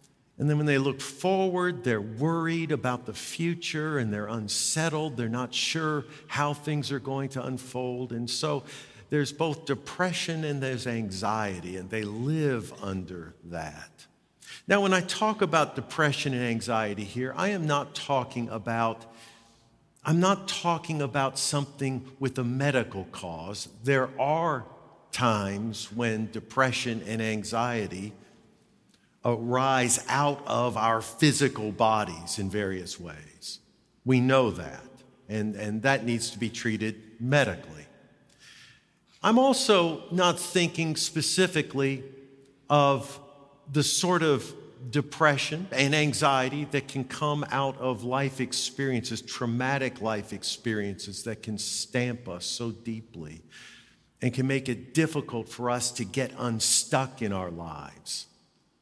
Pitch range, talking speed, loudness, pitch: 115-145 Hz, 130 wpm, -28 LUFS, 130 Hz